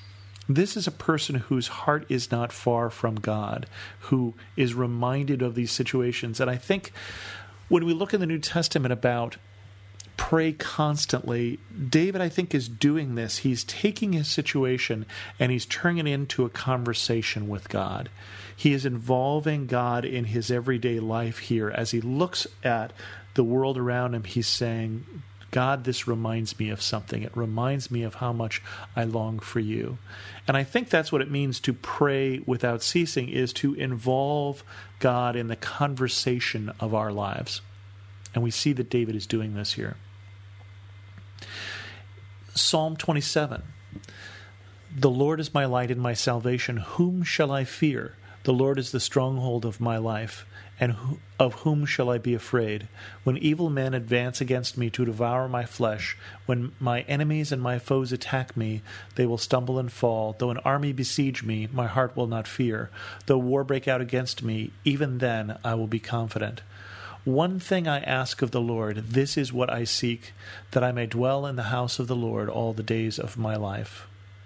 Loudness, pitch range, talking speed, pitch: -27 LUFS, 110-135 Hz, 175 wpm, 120 Hz